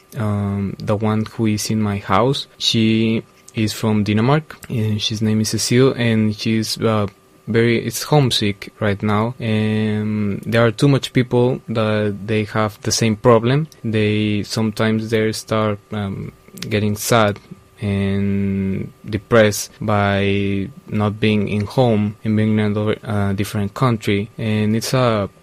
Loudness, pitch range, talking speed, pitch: -18 LUFS, 105-115 Hz, 140 wpm, 110 Hz